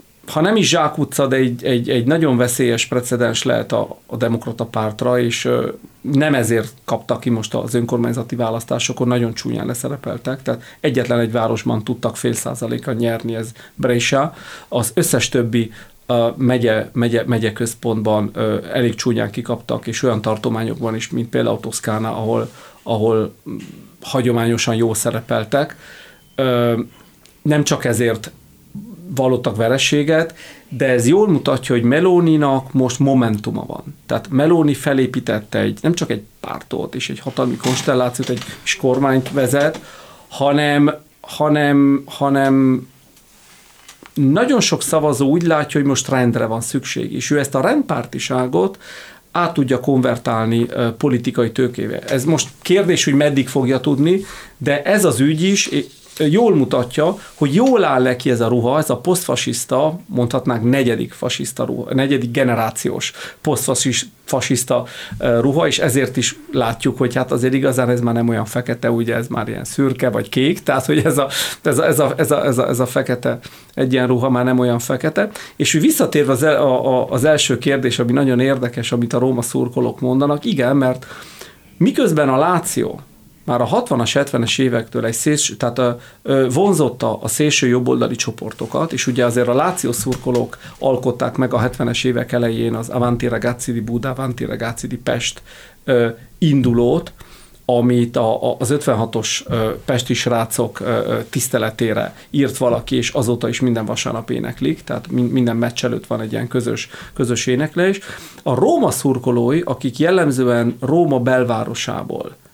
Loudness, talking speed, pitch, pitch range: -17 LUFS, 145 wpm, 125 Hz, 120-140 Hz